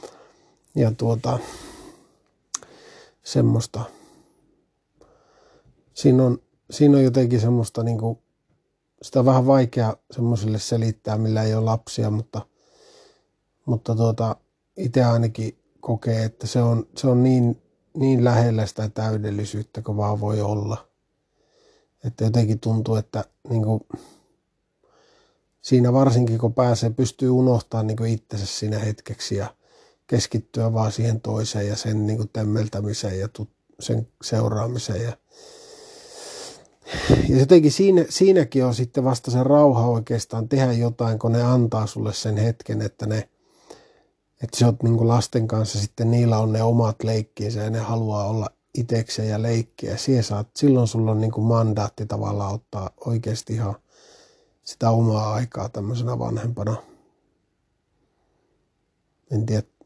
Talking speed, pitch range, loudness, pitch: 125 wpm, 110-125 Hz, -22 LUFS, 115 Hz